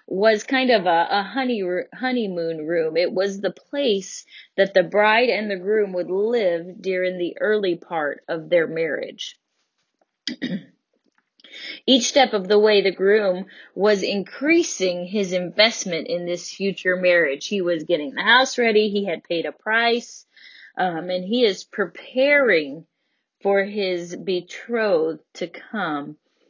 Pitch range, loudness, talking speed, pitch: 180-225 Hz, -21 LUFS, 145 wpm, 195 Hz